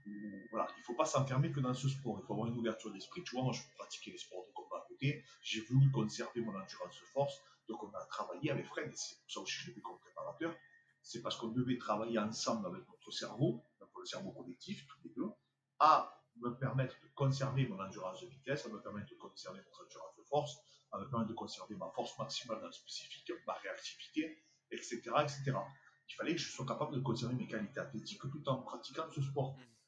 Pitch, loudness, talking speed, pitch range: 135 Hz, -40 LUFS, 225 wpm, 115-145 Hz